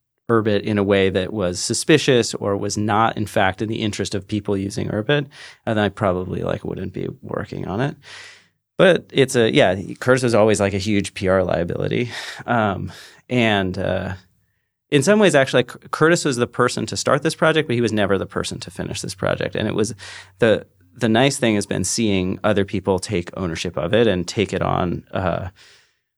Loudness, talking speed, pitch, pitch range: -20 LUFS, 195 wpm, 105 Hz, 100-120 Hz